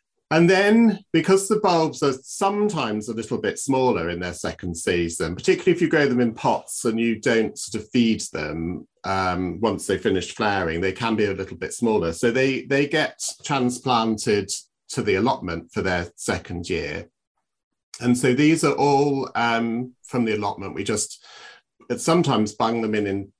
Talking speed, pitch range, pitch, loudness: 175 wpm, 100-145 Hz, 115 Hz, -22 LUFS